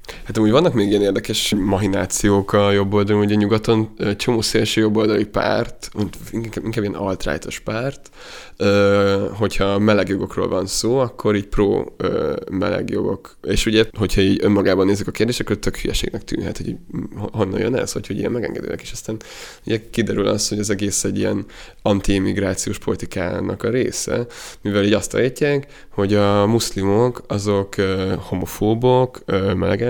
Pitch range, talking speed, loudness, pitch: 100-110 Hz, 145 wpm, -19 LUFS, 105 Hz